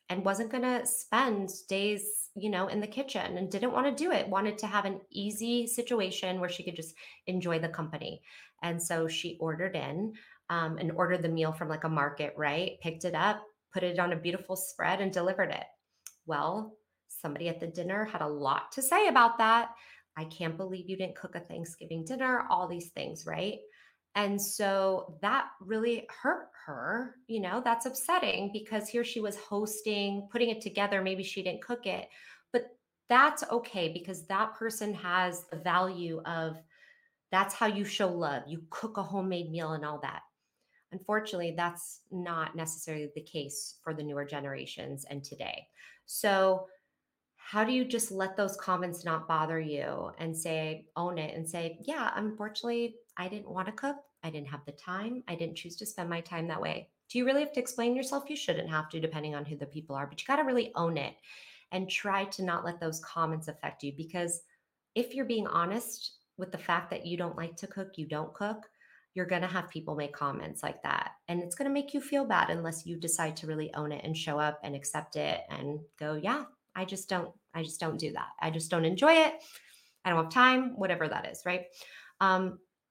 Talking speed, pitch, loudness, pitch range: 205 wpm, 185 Hz, -33 LUFS, 165-215 Hz